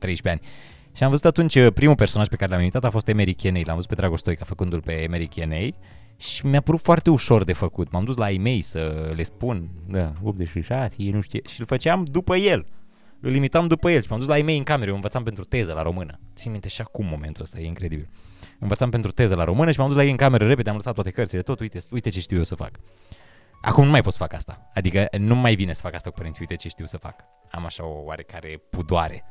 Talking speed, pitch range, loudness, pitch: 255 wpm, 90-125 Hz, -22 LUFS, 100 Hz